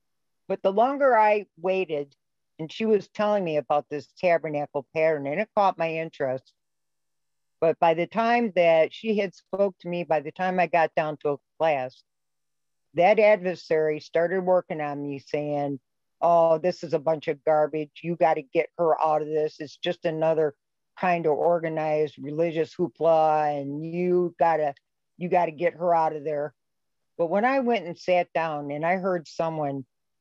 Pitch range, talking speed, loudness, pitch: 150-180 Hz, 175 wpm, -25 LUFS, 165 Hz